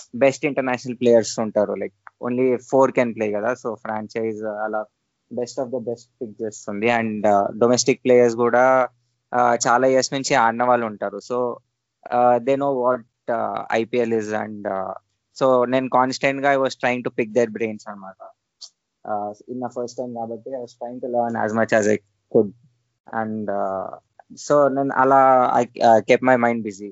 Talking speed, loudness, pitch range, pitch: 120 wpm, -20 LUFS, 110-125 Hz, 120 Hz